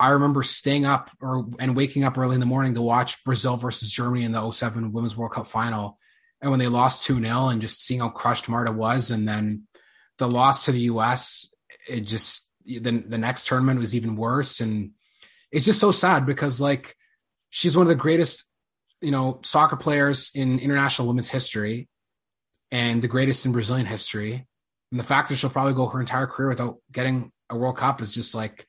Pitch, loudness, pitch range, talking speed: 125 Hz, -23 LUFS, 115-135 Hz, 200 wpm